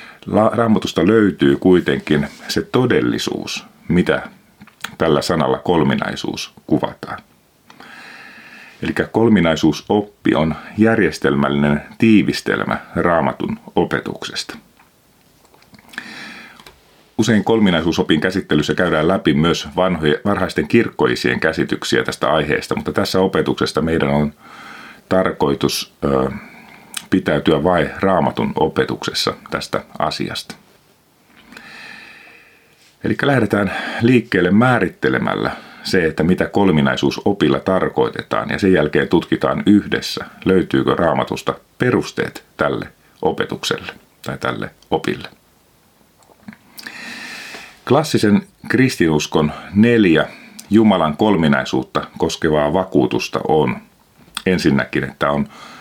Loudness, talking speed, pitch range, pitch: -17 LUFS, 80 wpm, 75-105 Hz, 90 Hz